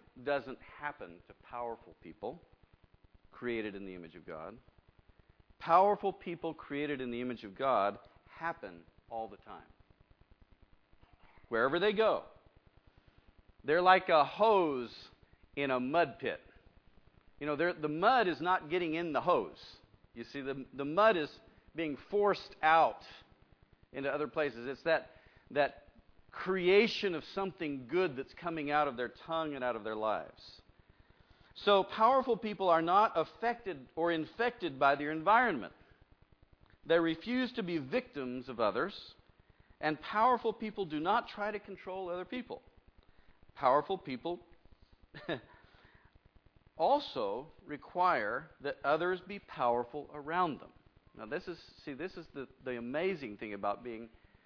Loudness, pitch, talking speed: -33 LUFS, 135 Hz, 140 wpm